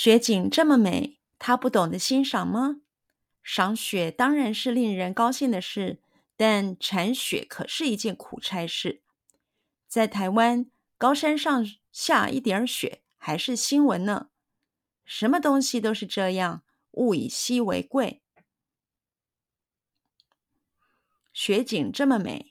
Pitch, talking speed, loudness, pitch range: 240 Hz, 175 characters per minute, -25 LUFS, 210-270 Hz